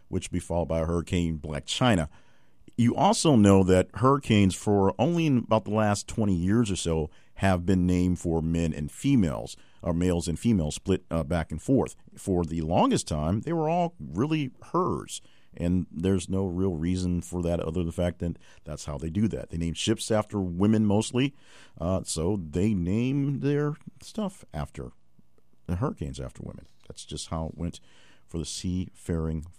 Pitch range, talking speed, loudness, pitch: 80-105 Hz, 185 wpm, -27 LUFS, 90 Hz